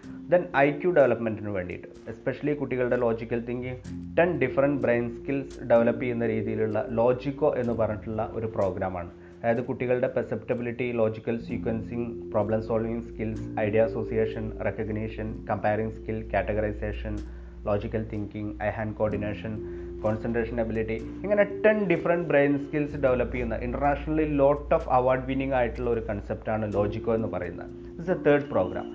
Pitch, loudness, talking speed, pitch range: 115 Hz, -27 LUFS, 135 wpm, 105-130 Hz